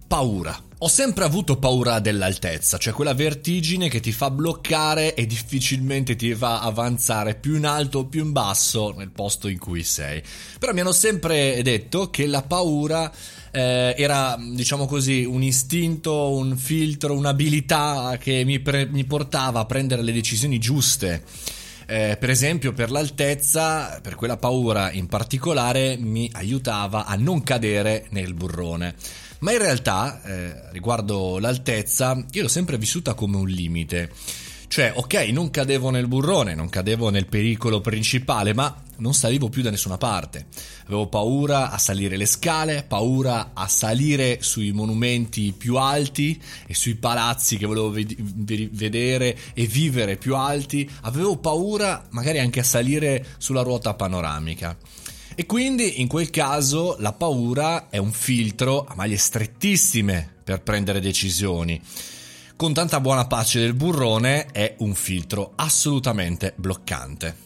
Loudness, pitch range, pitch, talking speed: -22 LUFS, 105-140 Hz, 120 Hz, 145 wpm